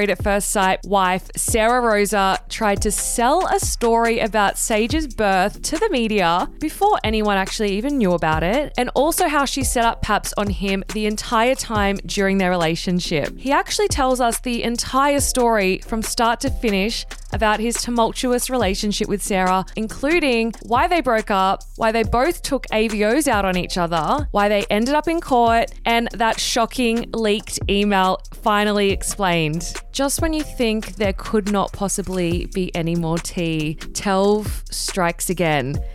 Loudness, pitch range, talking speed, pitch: -19 LUFS, 190-235 Hz, 165 wpm, 215 Hz